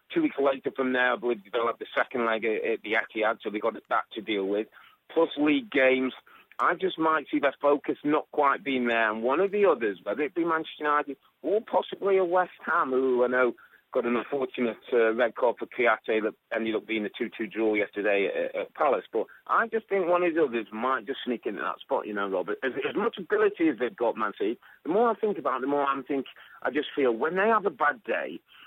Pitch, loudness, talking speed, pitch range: 145 Hz, -27 LUFS, 245 wpm, 125-200 Hz